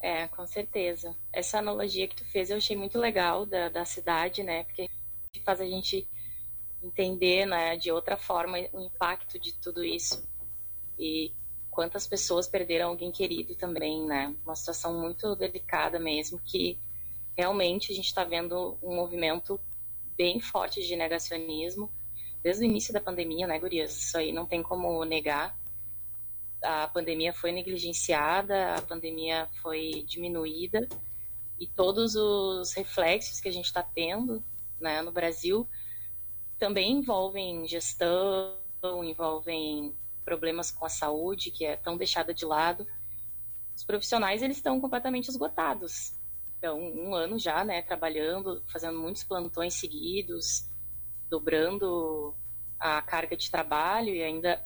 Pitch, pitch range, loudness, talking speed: 170 Hz, 155-185 Hz, -30 LUFS, 135 wpm